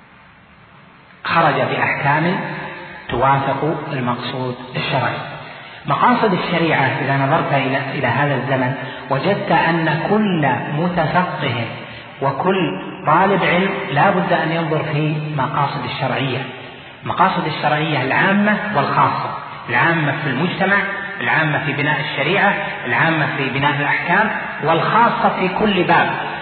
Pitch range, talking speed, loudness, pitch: 135-180 Hz, 100 wpm, -17 LUFS, 155 Hz